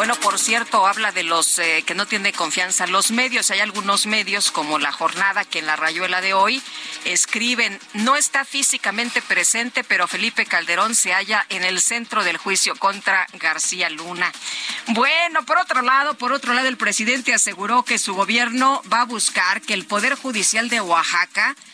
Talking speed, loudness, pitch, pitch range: 180 wpm, -18 LUFS, 210 Hz, 185-245 Hz